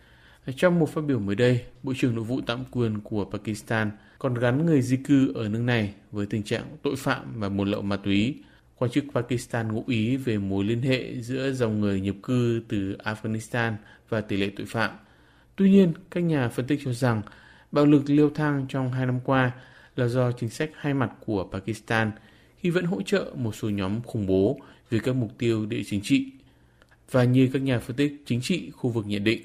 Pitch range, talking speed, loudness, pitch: 110-135 Hz, 215 wpm, -26 LUFS, 120 Hz